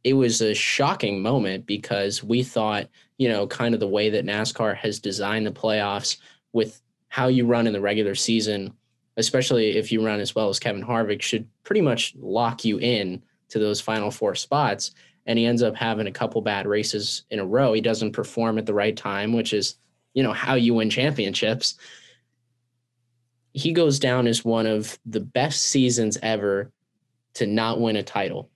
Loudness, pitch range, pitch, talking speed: -23 LUFS, 105-120 Hz, 110 Hz, 190 wpm